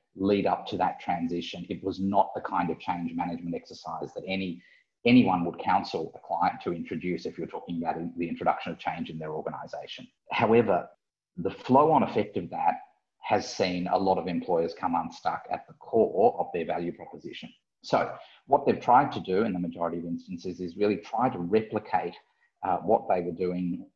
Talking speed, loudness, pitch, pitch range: 195 wpm, -28 LUFS, 90 Hz, 85-100 Hz